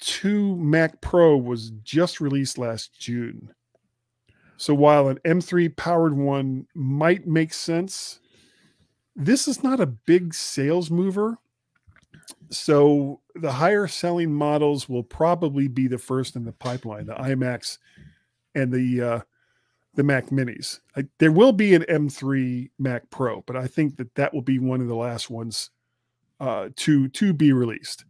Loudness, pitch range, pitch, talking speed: -23 LUFS, 125-165 Hz, 140 Hz, 150 wpm